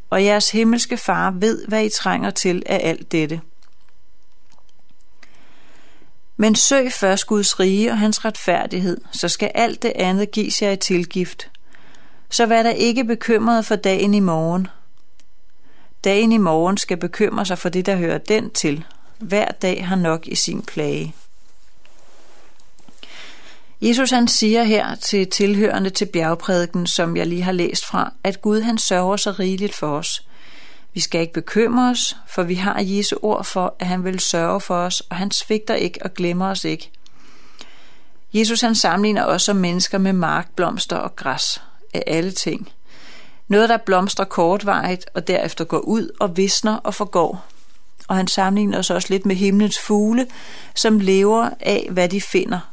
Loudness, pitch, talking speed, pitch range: -18 LUFS, 195 Hz, 165 wpm, 180-215 Hz